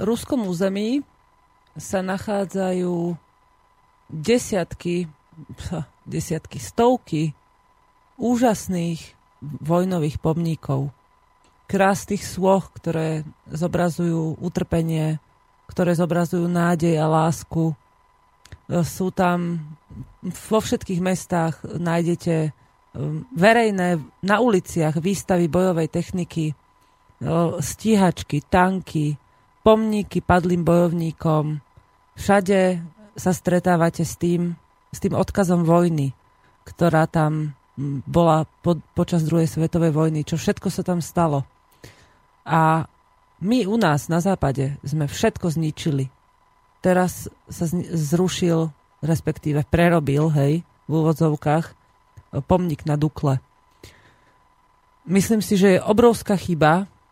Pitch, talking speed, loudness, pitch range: 170 Hz, 90 wpm, -21 LUFS, 150-180 Hz